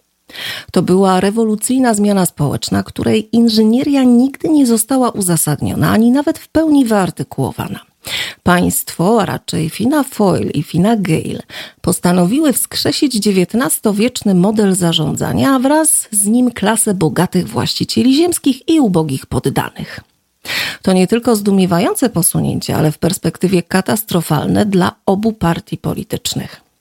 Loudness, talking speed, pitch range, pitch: -14 LUFS, 120 wpm, 170-240 Hz, 200 Hz